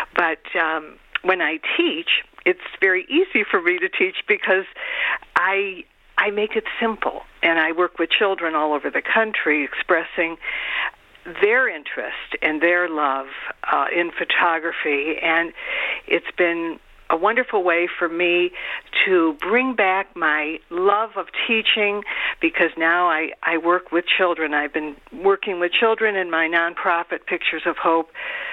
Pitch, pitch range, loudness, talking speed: 180 Hz, 165-230 Hz, -20 LUFS, 145 wpm